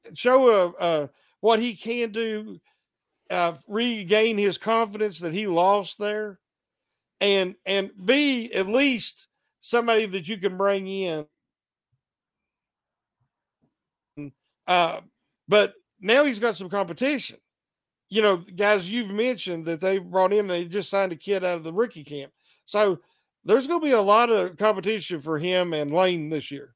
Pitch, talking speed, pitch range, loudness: 200 Hz, 155 wpm, 175-225 Hz, -24 LUFS